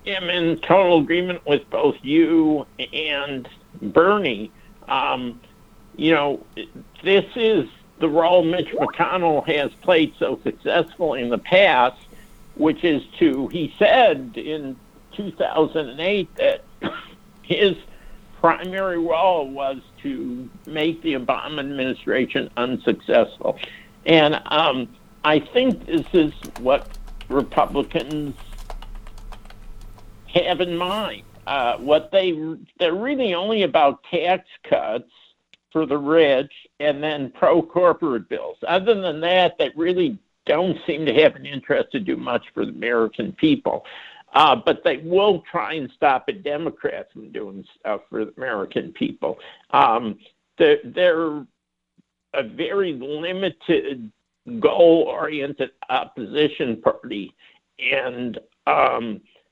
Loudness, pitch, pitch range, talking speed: -21 LUFS, 165 Hz, 140-190 Hz, 115 wpm